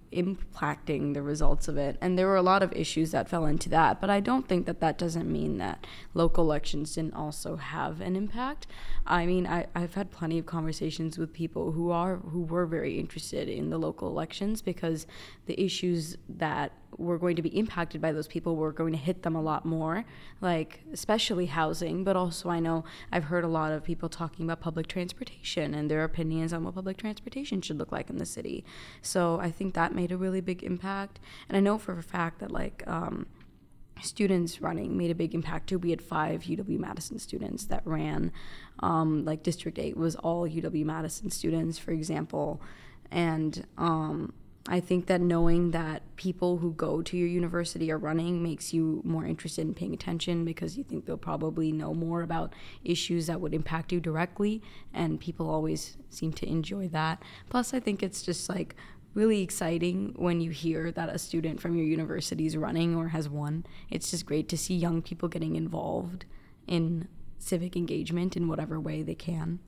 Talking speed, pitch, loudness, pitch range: 195 wpm, 165 Hz, -31 LUFS, 160-180 Hz